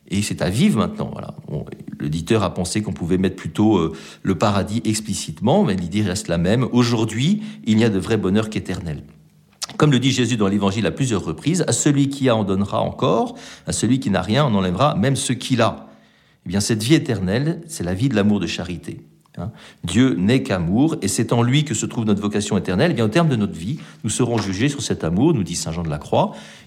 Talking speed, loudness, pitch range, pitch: 230 wpm, -20 LUFS, 95-125 Hz, 110 Hz